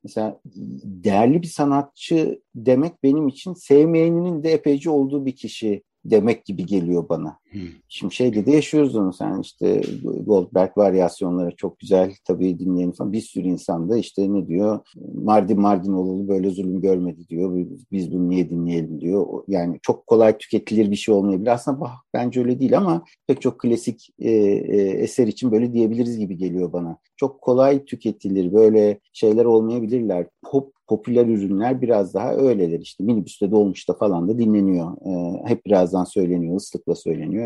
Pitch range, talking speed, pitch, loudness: 90-125 Hz, 160 wpm, 100 Hz, -20 LUFS